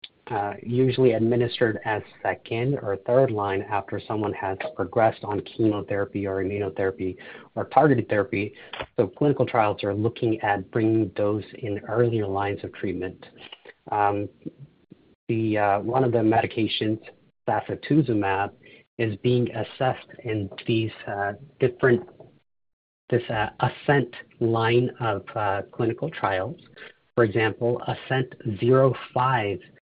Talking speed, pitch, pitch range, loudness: 120 wpm, 110 Hz, 100-120 Hz, -25 LUFS